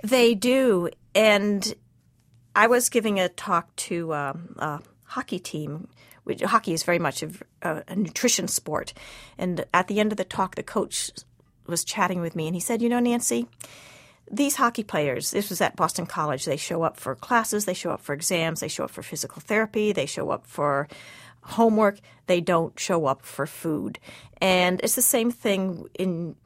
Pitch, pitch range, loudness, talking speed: 180 Hz, 155-215 Hz, -25 LUFS, 185 wpm